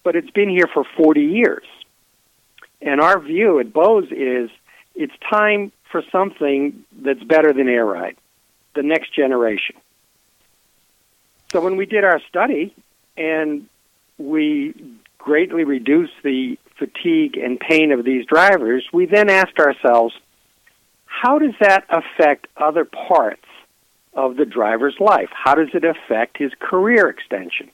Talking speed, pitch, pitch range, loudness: 135 wpm, 160 Hz, 140-205 Hz, -17 LUFS